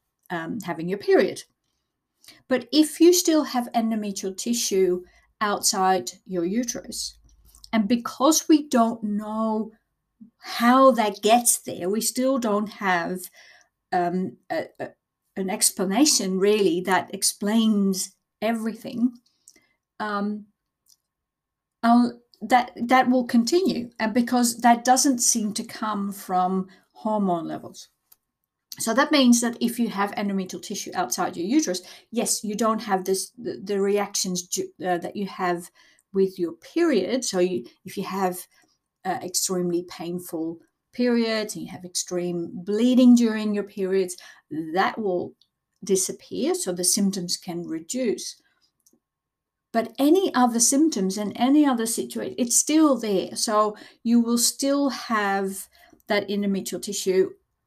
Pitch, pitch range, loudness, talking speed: 215 Hz, 190-245 Hz, -23 LUFS, 125 wpm